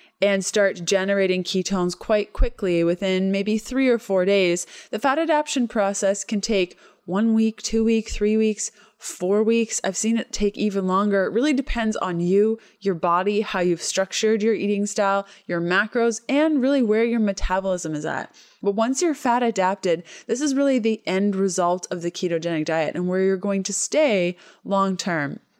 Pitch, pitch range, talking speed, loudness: 200 Hz, 185-225 Hz, 180 wpm, -22 LUFS